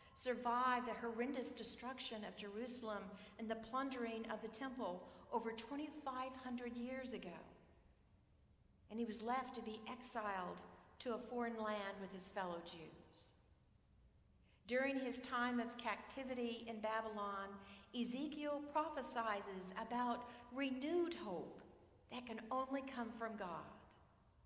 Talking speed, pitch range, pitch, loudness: 120 wpm, 215-255 Hz, 235 Hz, -46 LUFS